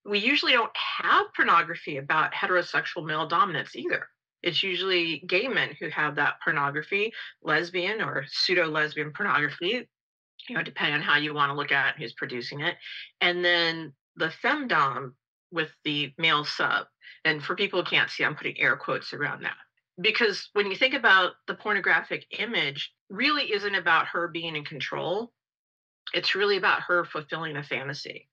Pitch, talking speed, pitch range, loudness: 165 Hz, 165 wpm, 150-200 Hz, -26 LUFS